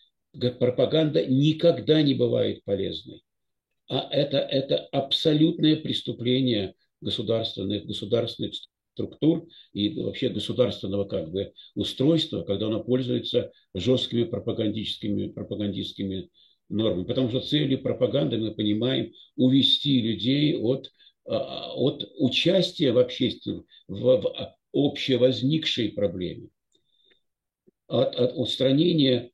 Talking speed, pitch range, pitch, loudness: 90 wpm, 105-140 Hz, 125 Hz, -25 LUFS